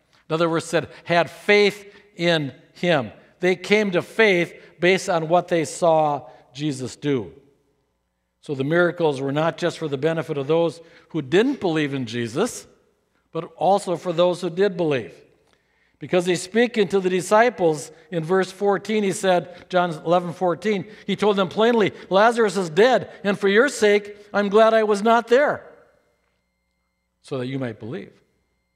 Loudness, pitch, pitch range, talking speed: -21 LUFS, 175 Hz, 155-200 Hz, 165 wpm